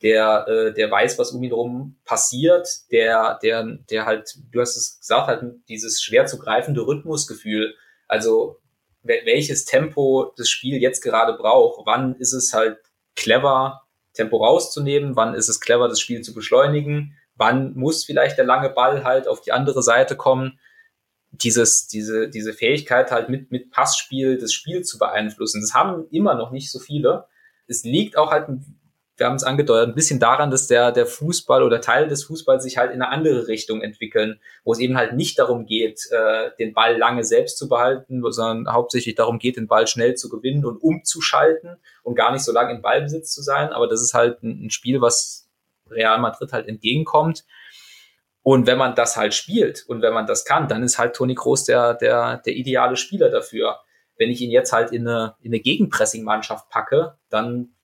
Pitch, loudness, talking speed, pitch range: 125 Hz, -19 LUFS, 190 wpm, 115-150 Hz